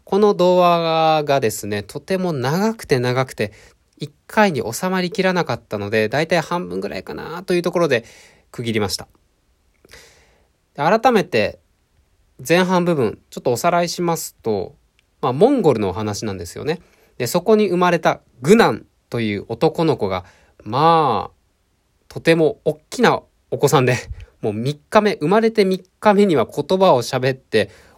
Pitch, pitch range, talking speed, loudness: 155 Hz, 120-180 Hz, 300 characters per minute, -18 LUFS